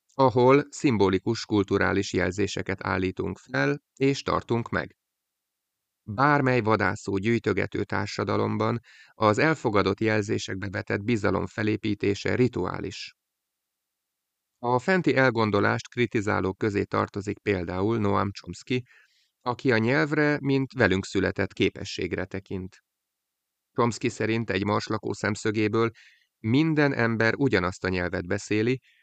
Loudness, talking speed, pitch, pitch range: -26 LUFS, 100 wpm, 110 Hz, 100-125 Hz